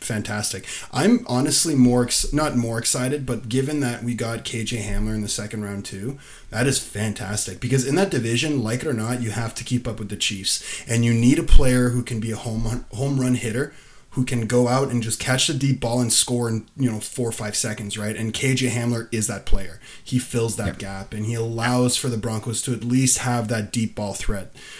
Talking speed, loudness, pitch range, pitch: 230 wpm, -22 LUFS, 110-125 Hz, 120 Hz